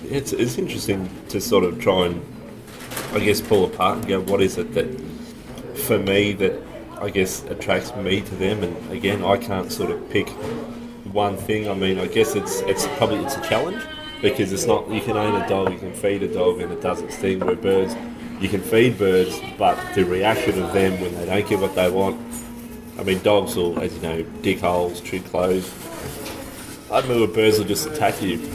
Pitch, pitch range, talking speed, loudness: 95 Hz, 90-110 Hz, 210 wpm, -22 LUFS